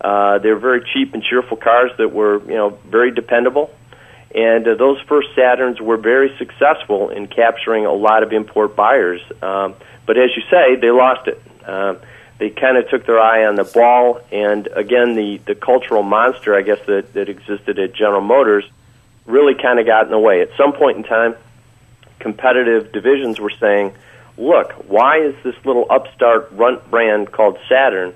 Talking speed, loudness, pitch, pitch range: 185 wpm, -14 LUFS, 115 Hz, 105-125 Hz